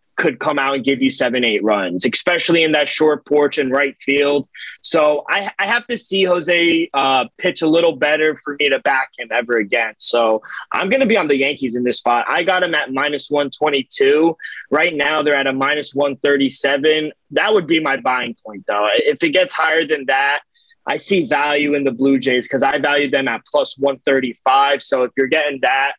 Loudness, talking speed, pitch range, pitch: -16 LUFS, 210 wpm, 135-170 Hz, 145 Hz